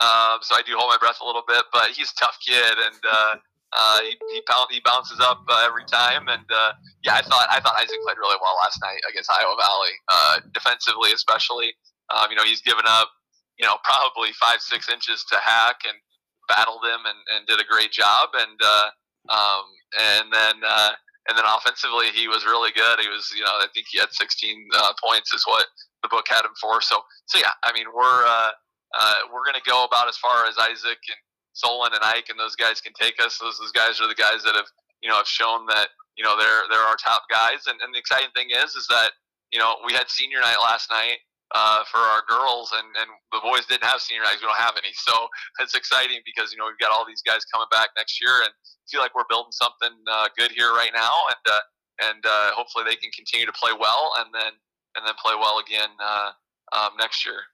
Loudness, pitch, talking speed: -20 LUFS, 370 Hz, 235 wpm